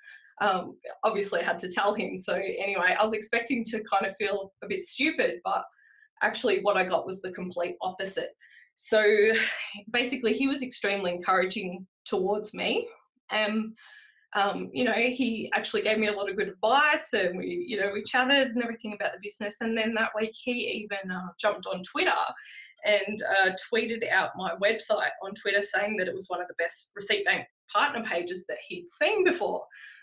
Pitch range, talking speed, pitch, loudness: 195-250 Hz, 190 wpm, 215 Hz, -28 LUFS